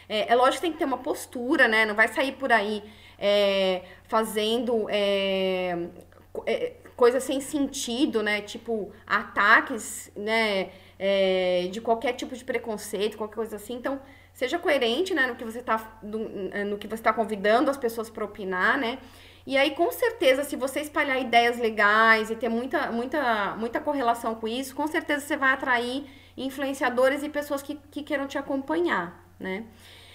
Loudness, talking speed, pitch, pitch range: -25 LUFS, 165 wpm, 235 Hz, 215-280 Hz